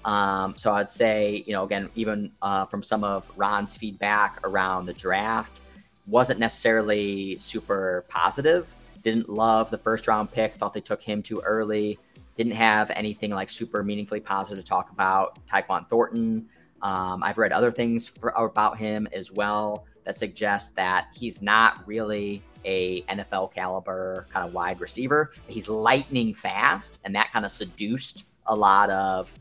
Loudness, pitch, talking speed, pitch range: -25 LUFS, 105 Hz, 160 wpm, 95-110 Hz